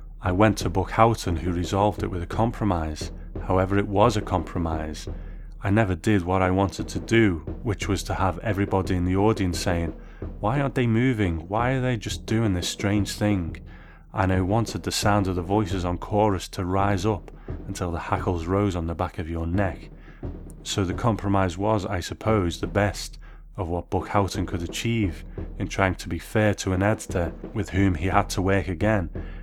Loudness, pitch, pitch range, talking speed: -25 LUFS, 95 Hz, 90-105 Hz, 200 wpm